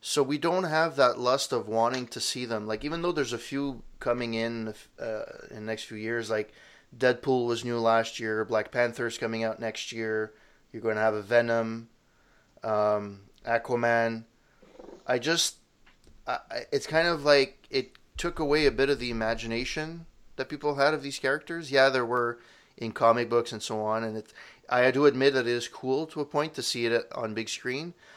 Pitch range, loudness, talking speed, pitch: 115-140 Hz, -28 LUFS, 200 wpm, 120 Hz